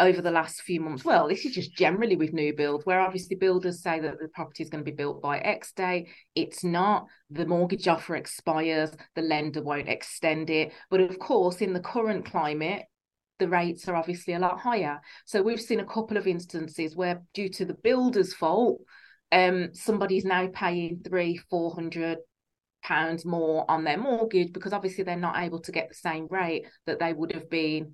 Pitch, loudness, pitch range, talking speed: 175 Hz, -28 LUFS, 160-185 Hz, 200 wpm